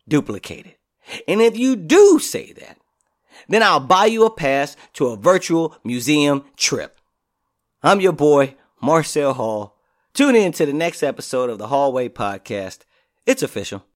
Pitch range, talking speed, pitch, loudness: 125-185 Hz, 150 wpm, 145 Hz, -18 LUFS